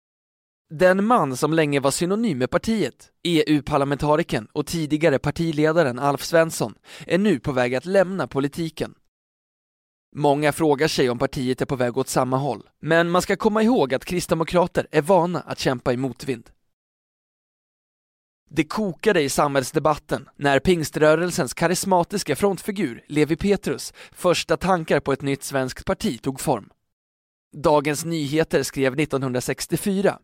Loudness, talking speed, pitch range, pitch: -22 LUFS, 135 wpm, 135-175 Hz, 155 Hz